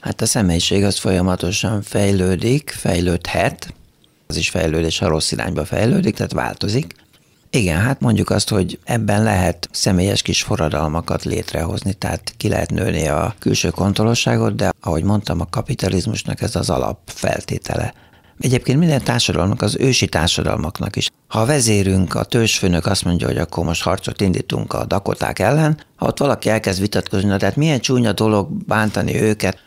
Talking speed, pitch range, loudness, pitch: 155 wpm, 90-110 Hz, -18 LUFS, 100 Hz